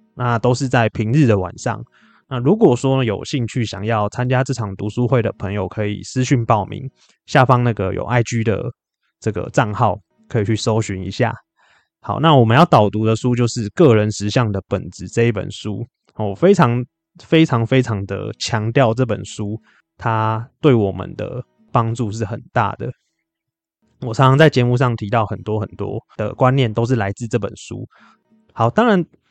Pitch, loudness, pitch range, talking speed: 115 Hz, -18 LUFS, 105-130 Hz, 255 characters per minute